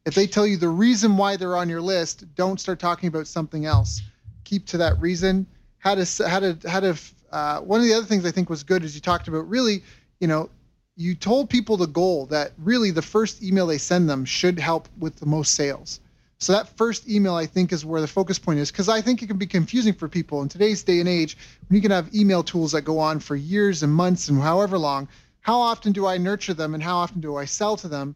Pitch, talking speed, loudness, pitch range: 180 Hz, 255 wpm, -22 LUFS, 155-200 Hz